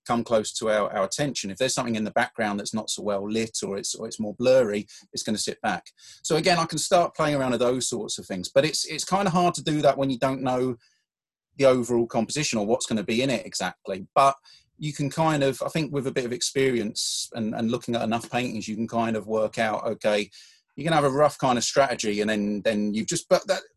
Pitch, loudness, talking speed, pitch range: 125 Hz, -25 LUFS, 260 wpm, 110-145 Hz